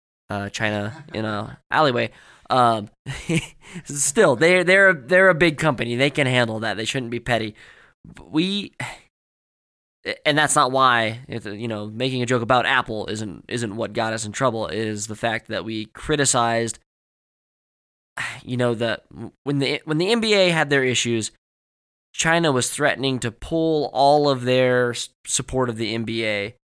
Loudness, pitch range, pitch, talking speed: -21 LUFS, 110-145 Hz, 125 Hz, 165 wpm